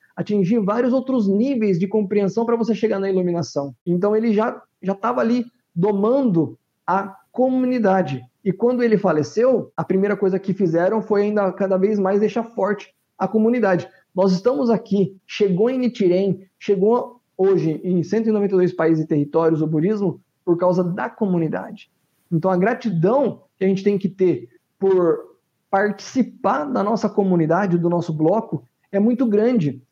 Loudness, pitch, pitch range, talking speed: -20 LUFS, 195 Hz, 180-220 Hz, 155 wpm